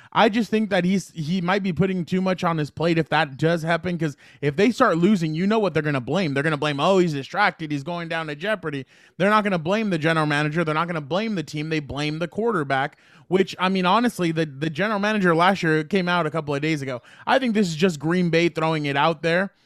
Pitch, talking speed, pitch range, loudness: 170 Hz, 270 wpm, 155-190 Hz, -22 LUFS